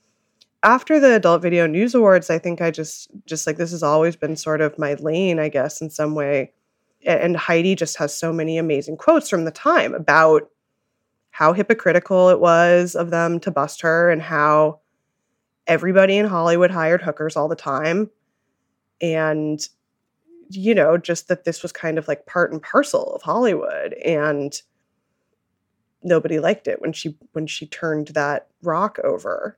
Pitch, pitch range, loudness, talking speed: 165 Hz, 155-180 Hz, -19 LUFS, 170 wpm